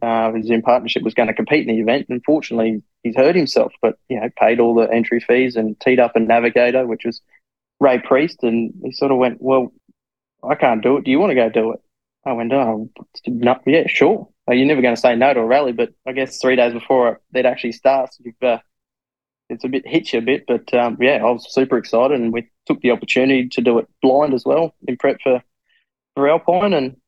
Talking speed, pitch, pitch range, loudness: 240 wpm, 125 Hz, 115-130 Hz, -17 LUFS